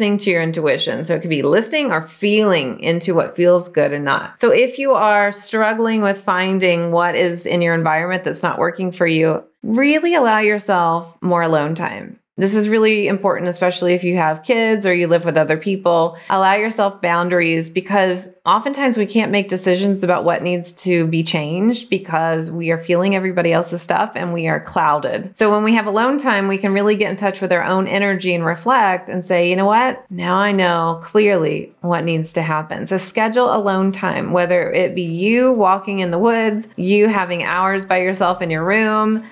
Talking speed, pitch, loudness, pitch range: 200 wpm, 185 Hz, -17 LUFS, 170-210 Hz